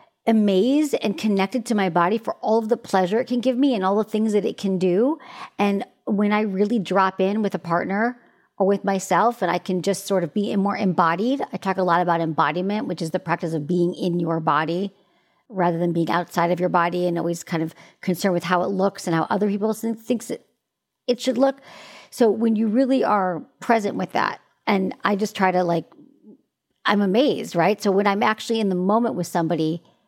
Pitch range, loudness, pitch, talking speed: 175-220 Hz, -22 LUFS, 195 Hz, 215 wpm